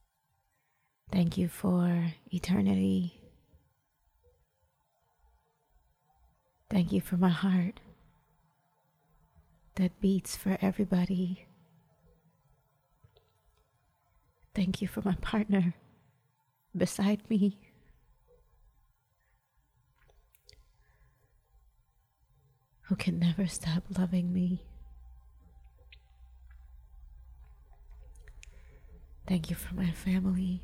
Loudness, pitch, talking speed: -31 LUFS, 170 Hz, 60 wpm